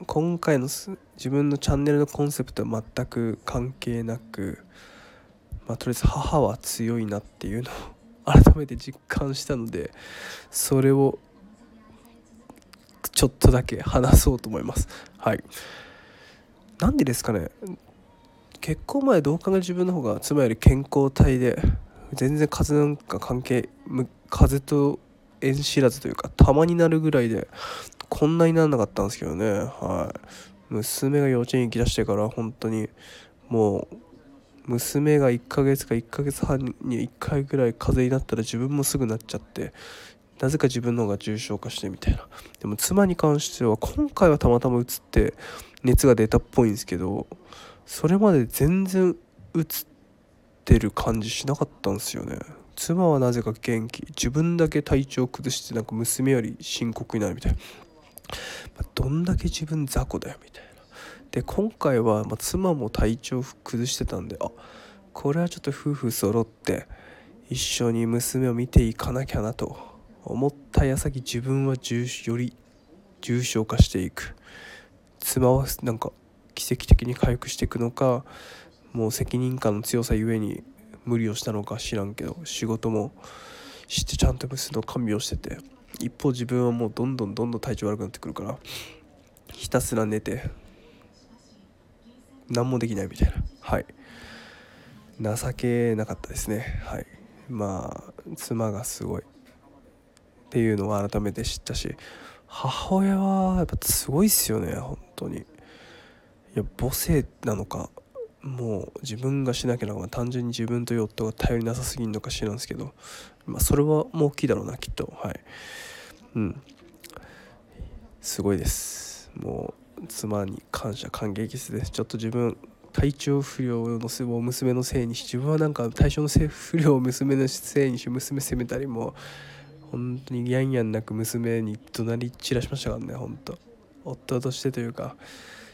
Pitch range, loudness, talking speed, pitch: 110-140 Hz, -25 LUFS, 295 characters per minute, 125 Hz